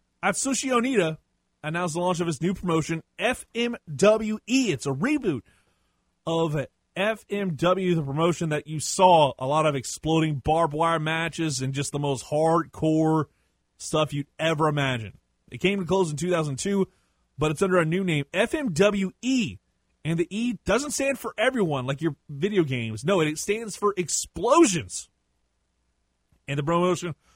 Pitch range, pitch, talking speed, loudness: 150-195 Hz, 165 Hz, 150 wpm, -25 LUFS